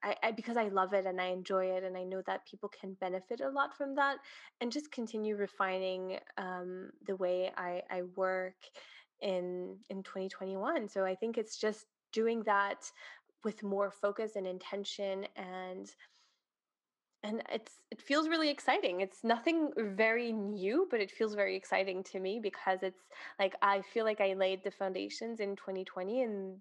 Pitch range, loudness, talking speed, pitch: 190-225 Hz, -36 LUFS, 180 wpm, 195 Hz